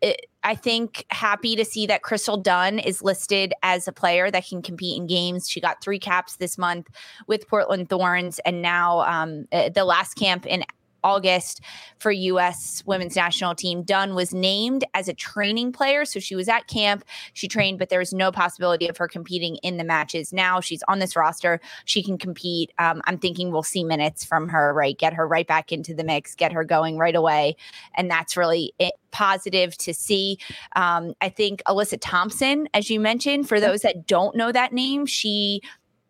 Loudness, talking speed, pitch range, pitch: -22 LUFS, 195 wpm, 170-205 Hz, 180 Hz